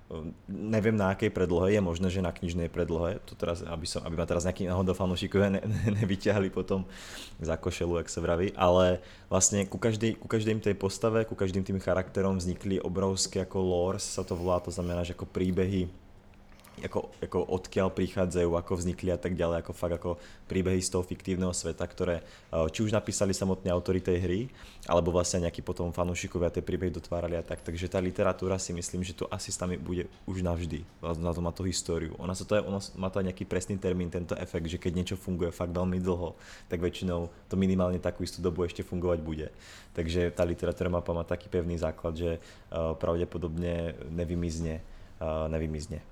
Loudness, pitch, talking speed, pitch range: -31 LUFS, 90 Hz, 185 wpm, 85-95 Hz